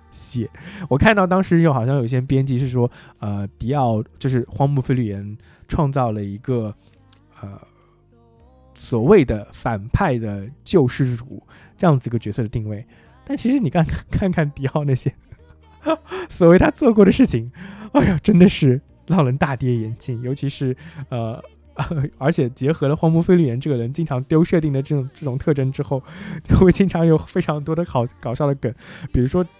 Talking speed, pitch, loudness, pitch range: 260 characters per minute, 135 Hz, -19 LUFS, 115-165 Hz